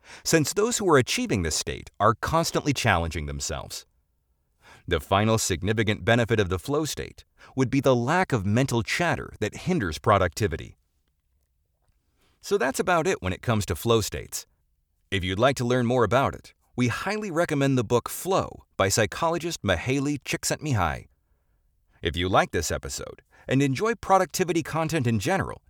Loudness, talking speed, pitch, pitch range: -25 LUFS, 160 wpm, 115 Hz, 85-140 Hz